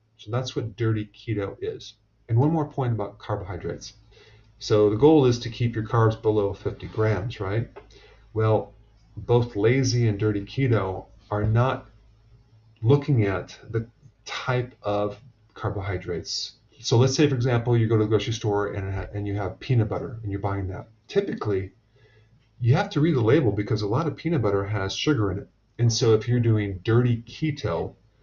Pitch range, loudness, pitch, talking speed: 105-125 Hz, -25 LUFS, 110 Hz, 180 wpm